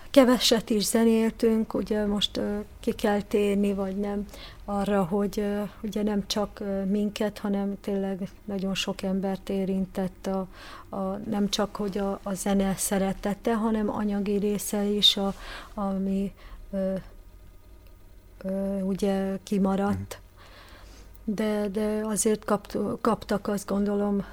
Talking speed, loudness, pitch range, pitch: 125 wpm, -27 LUFS, 195-210 Hz, 200 Hz